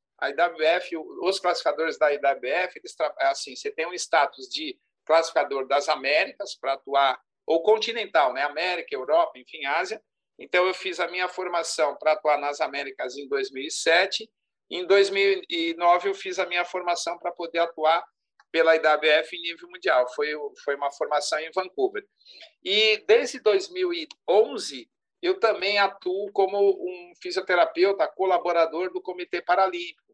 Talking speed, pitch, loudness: 140 wpm, 185 Hz, -24 LUFS